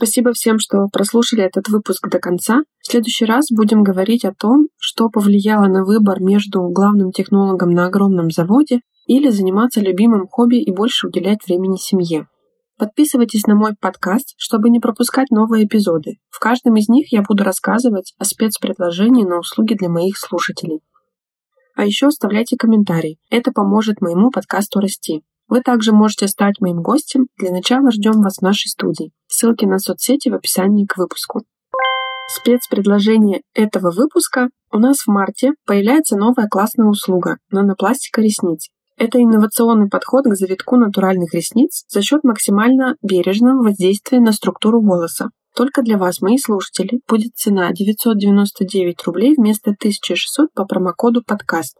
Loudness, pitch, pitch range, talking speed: -15 LUFS, 215 Hz, 190-240 Hz, 150 wpm